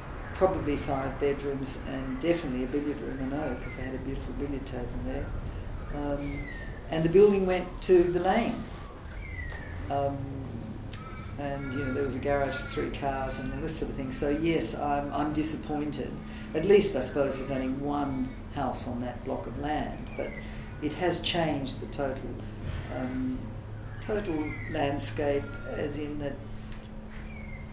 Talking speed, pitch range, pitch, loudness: 160 wpm, 110-145 Hz, 135 Hz, -30 LUFS